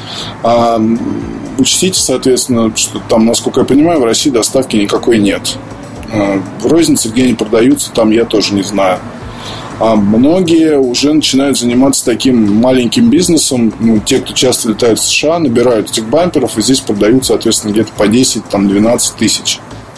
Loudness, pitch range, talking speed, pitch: -10 LUFS, 110-130 Hz, 145 wpm, 115 Hz